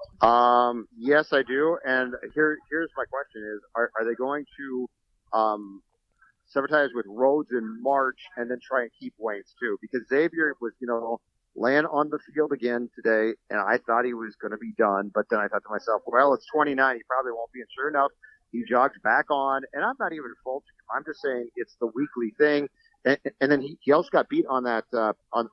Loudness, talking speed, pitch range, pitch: -26 LUFS, 215 wpm, 115-145 Hz, 130 Hz